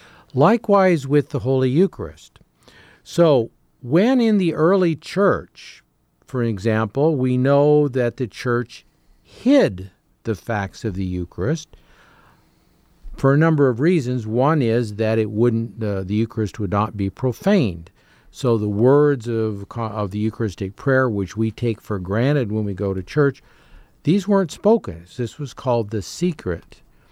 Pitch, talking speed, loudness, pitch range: 120 Hz, 150 wpm, -20 LUFS, 110-150 Hz